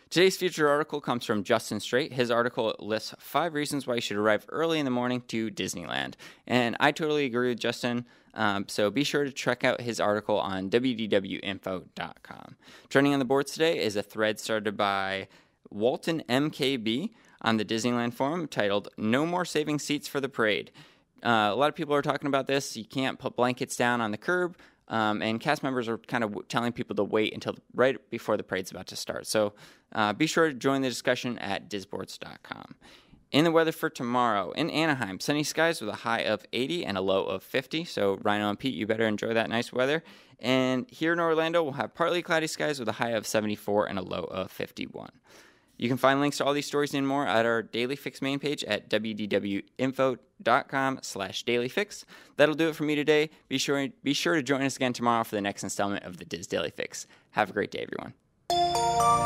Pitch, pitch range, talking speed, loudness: 130 Hz, 110-150 Hz, 210 wpm, -28 LUFS